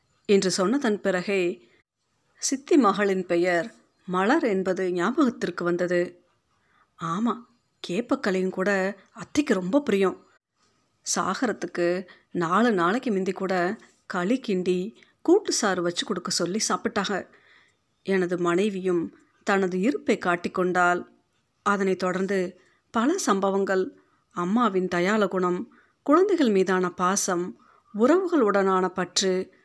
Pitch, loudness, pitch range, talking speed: 190 Hz, -25 LUFS, 180-225 Hz, 95 wpm